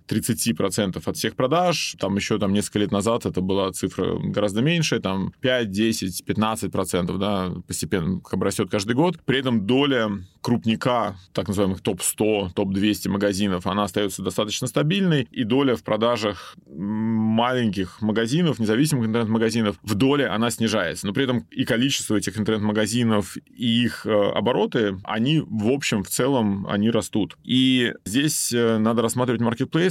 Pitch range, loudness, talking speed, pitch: 100-120 Hz, -22 LUFS, 140 wpm, 110 Hz